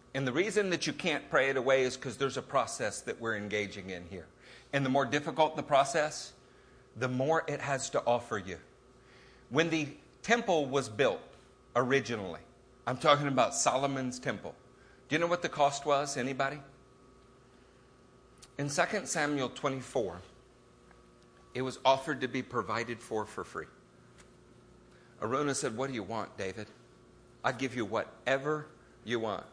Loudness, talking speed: -32 LUFS, 155 wpm